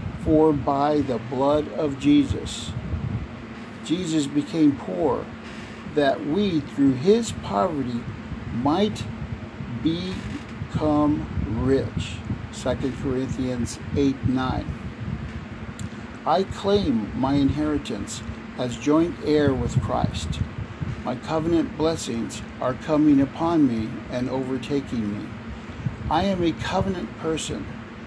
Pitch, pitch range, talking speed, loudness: 130 Hz, 115-150 Hz, 95 wpm, -24 LUFS